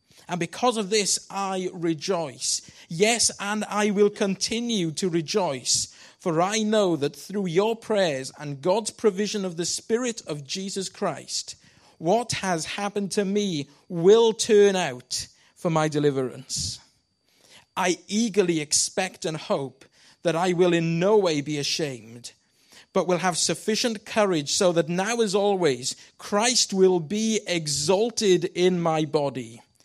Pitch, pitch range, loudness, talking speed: 185 Hz, 155-205 Hz, -24 LUFS, 140 wpm